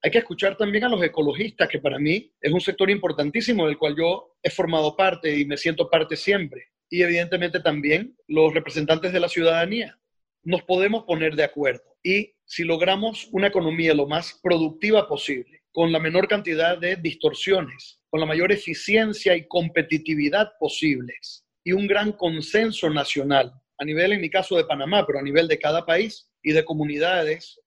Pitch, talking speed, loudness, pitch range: 170 Hz, 175 wpm, -22 LUFS, 155-195 Hz